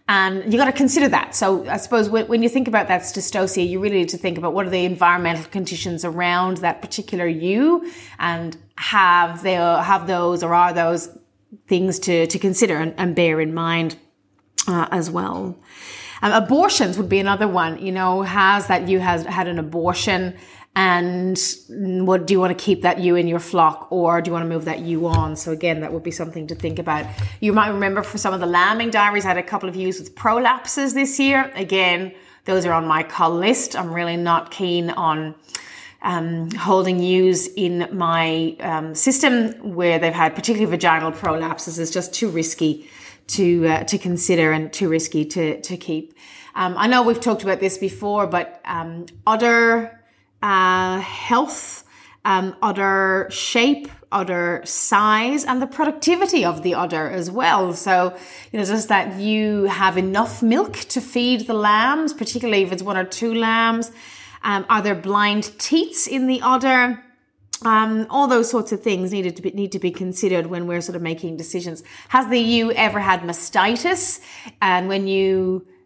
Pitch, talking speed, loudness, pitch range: 185 Hz, 185 wpm, -19 LUFS, 170-215 Hz